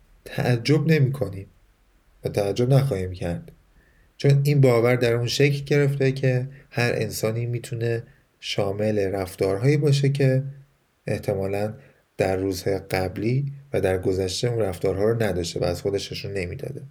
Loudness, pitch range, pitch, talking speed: -23 LUFS, 95-135 Hz, 120 Hz, 130 wpm